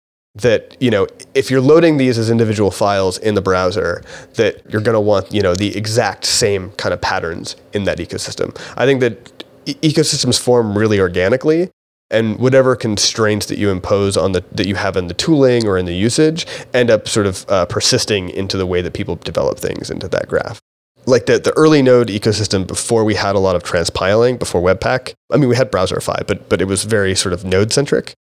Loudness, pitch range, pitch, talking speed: -15 LUFS, 100-130 Hz, 110 Hz, 210 wpm